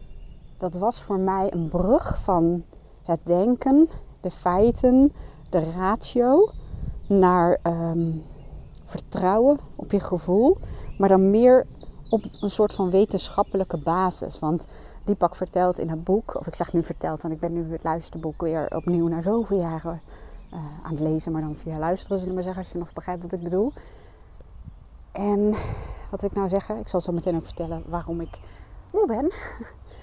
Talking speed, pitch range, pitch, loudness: 170 wpm, 165-205 Hz, 180 Hz, -24 LUFS